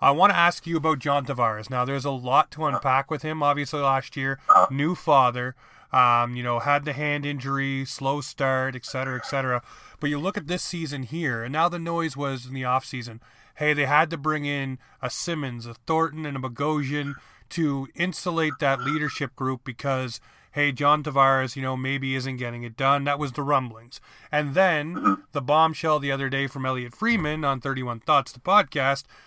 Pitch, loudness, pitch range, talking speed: 140 Hz, -24 LUFS, 130-150 Hz, 200 wpm